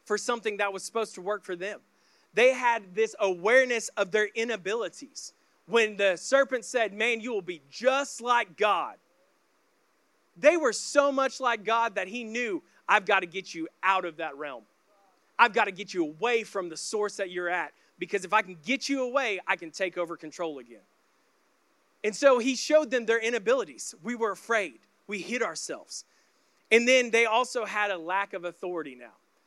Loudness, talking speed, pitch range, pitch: -27 LUFS, 190 wpm, 190-240 Hz, 215 Hz